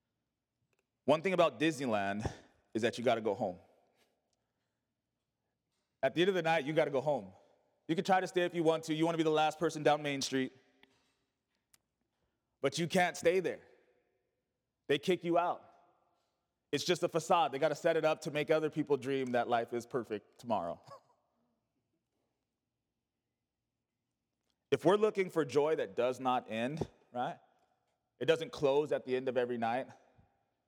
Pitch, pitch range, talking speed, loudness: 155 Hz, 135-175 Hz, 165 wpm, -34 LUFS